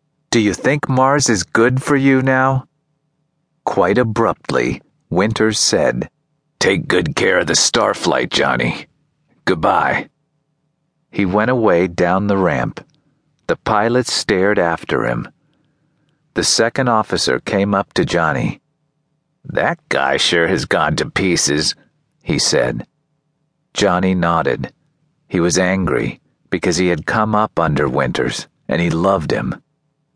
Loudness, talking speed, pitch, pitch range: -16 LUFS, 125 wpm, 125 Hz, 100-155 Hz